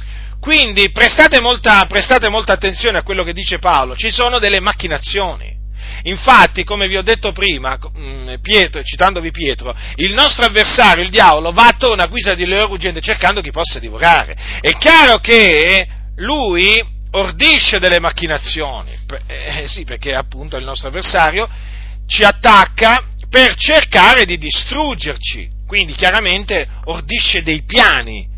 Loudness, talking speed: -10 LUFS, 135 wpm